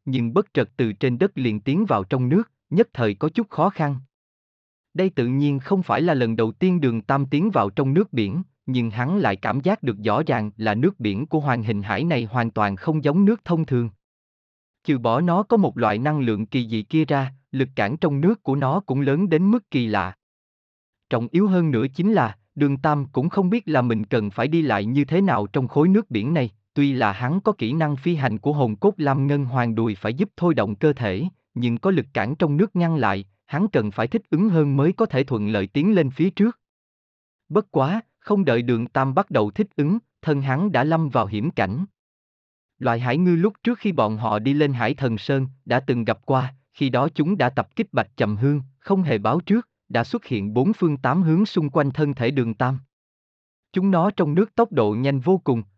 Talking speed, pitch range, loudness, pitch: 235 wpm, 115-170 Hz, -22 LUFS, 140 Hz